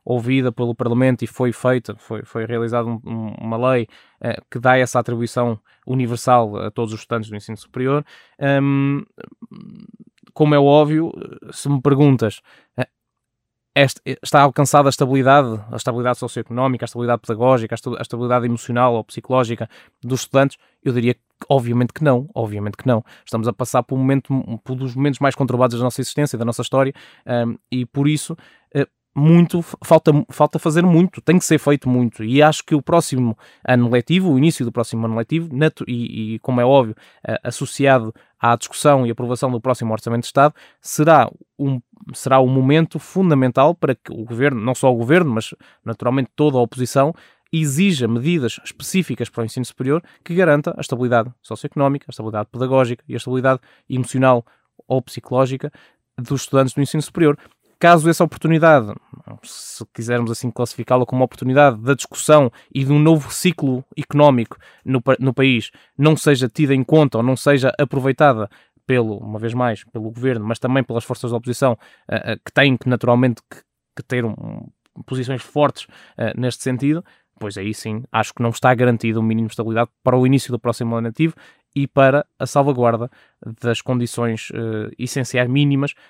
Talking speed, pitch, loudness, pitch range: 175 wpm, 130 Hz, -18 LUFS, 120-140 Hz